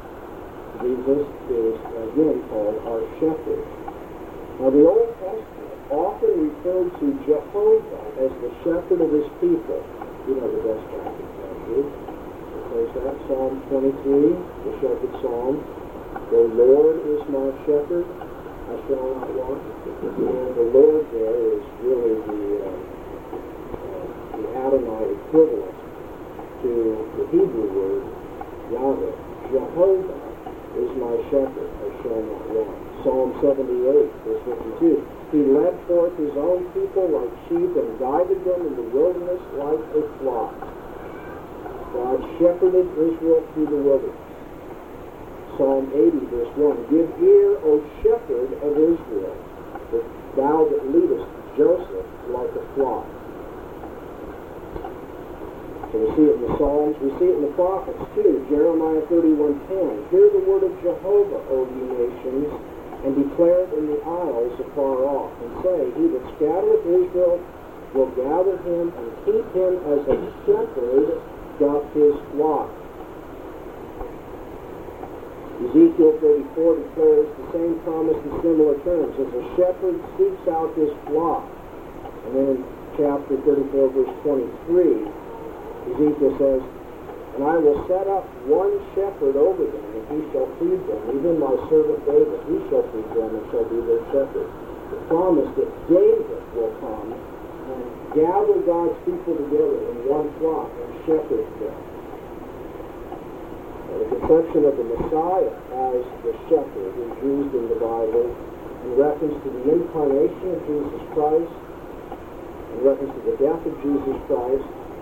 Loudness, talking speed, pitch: -21 LUFS, 135 wpm, 380 Hz